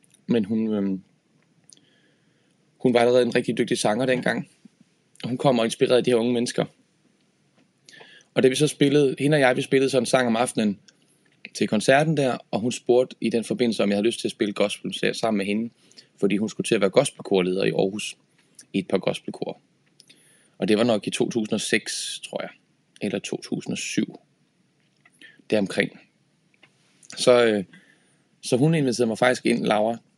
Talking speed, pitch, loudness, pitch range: 180 wpm, 125 Hz, -23 LUFS, 110-135 Hz